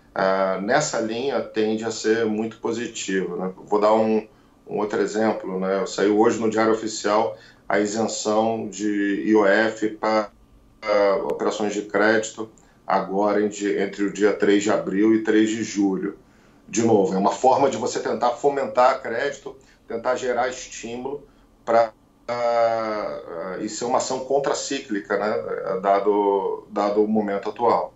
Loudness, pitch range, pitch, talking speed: -22 LUFS, 100-110 Hz, 110 Hz, 150 wpm